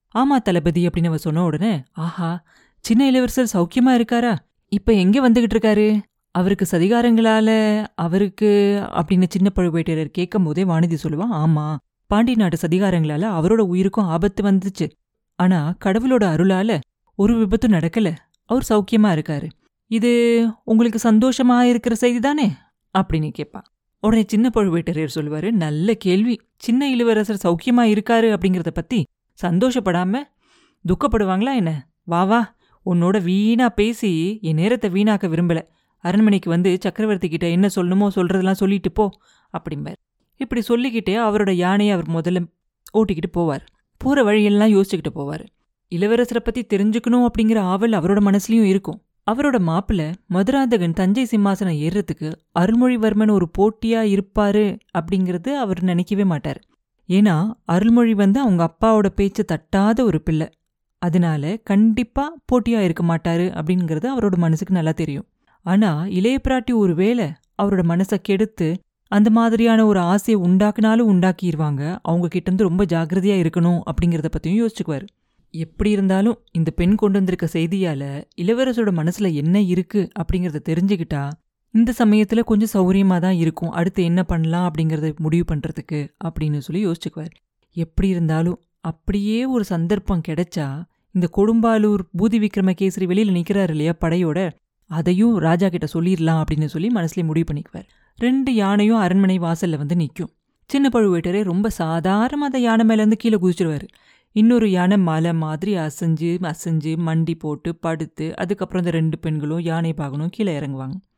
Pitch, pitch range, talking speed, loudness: 190 Hz, 170-220 Hz, 130 wpm, -19 LUFS